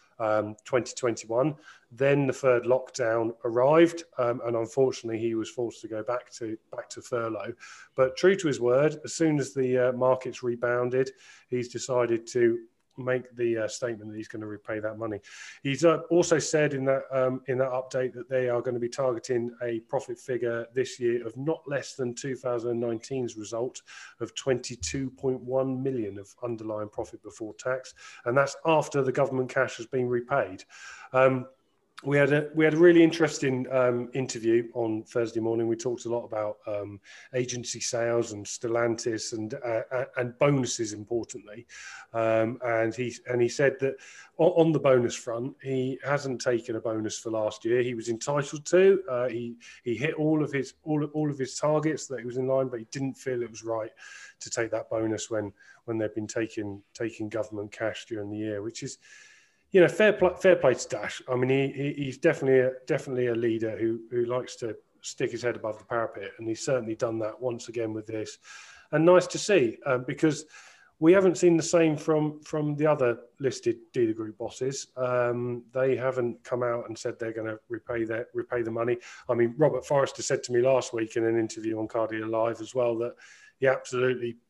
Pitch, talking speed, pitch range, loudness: 125 Hz, 195 wpm, 115-135 Hz, -28 LUFS